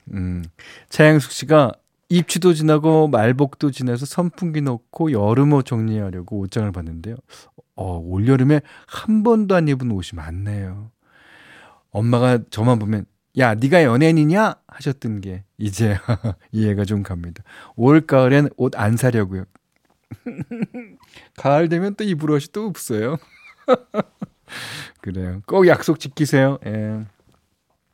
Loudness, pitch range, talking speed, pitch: -19 LUFS, 105-155 Hz, 250 characters per minute, 125 Hz